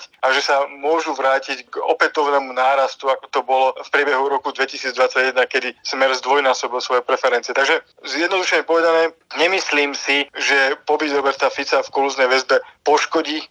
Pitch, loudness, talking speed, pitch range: 140 Hz, -18 LUFS, 145 wpm, 135-165 Hz